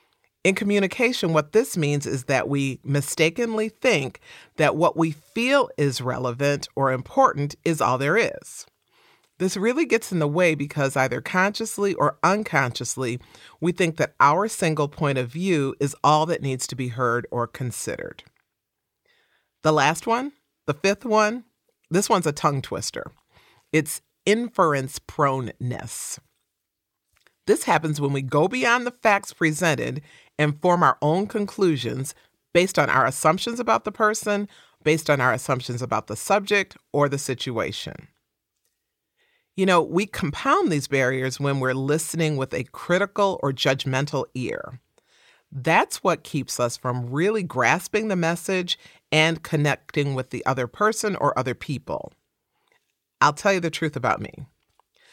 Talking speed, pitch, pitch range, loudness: 145 wpm, 155 Hz, 135-195 Hz, -23 LUFS